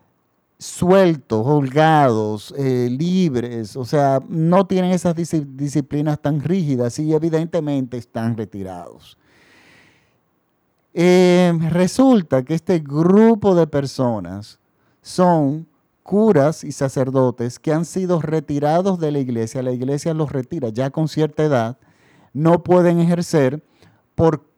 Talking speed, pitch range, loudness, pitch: 110 wpm, 130-170 Hz, -18 LUFS, 150 Hz